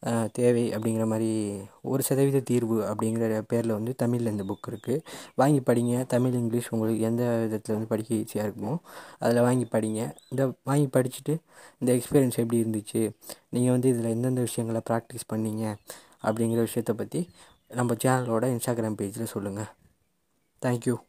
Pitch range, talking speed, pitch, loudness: 110-125 Hz, 140 wpm, 115 Hz, -27 LUFS